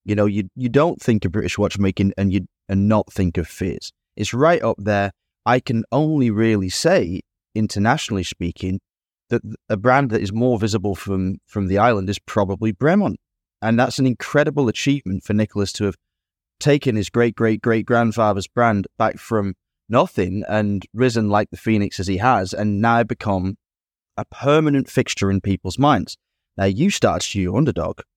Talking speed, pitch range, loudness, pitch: 180 wpm, 95-120 Hz, -20 LUFS, 105 Hz